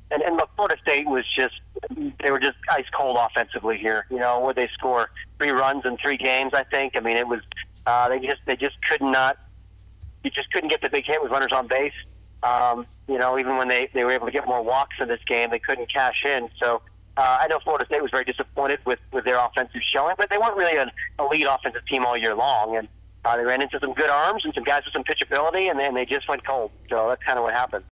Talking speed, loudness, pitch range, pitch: 260 wpm, -23 LUFS, 120-140 Hz, 130 Hz